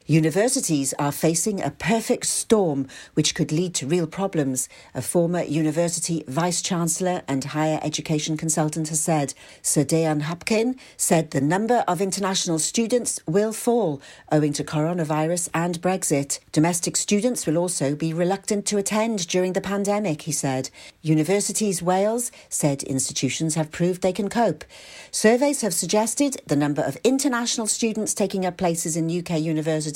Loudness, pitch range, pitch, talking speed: -23 LUFS, 155-205 Hz, 170 Hz, 150 wpm